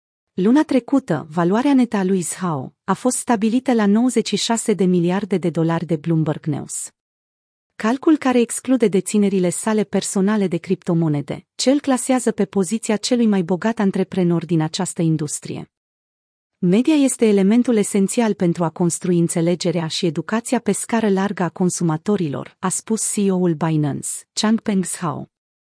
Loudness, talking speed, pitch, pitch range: -19 LUFS, 140 wpm, 195 Hz, 170-225 Hz